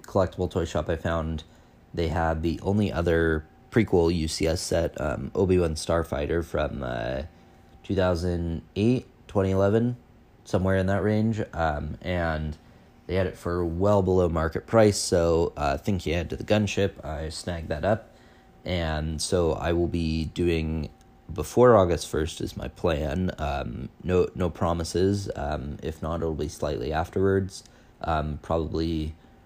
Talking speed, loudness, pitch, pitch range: 145 wpm, -26 LUFS, 85 Hz, 80-95 Hz